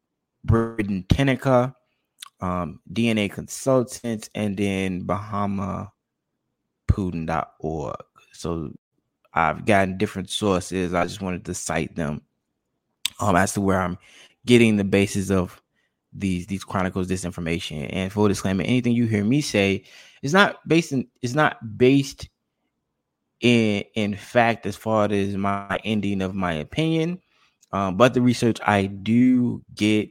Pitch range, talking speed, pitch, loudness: 95-120 Hz, 135 wpm, 100 Hz, -23 LUFS